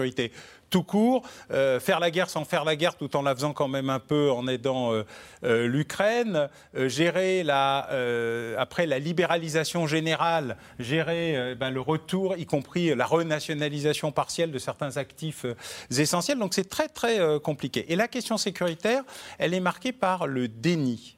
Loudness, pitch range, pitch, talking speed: -27 LUFS, 135-180 Hz, 160 Hz, 175 wpm